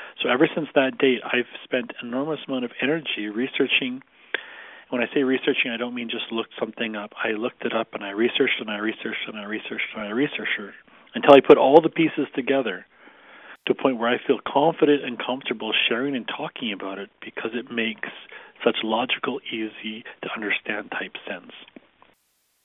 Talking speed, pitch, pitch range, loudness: 185 wpm, 130 Hz, 115-150 Hz, -23 LUFS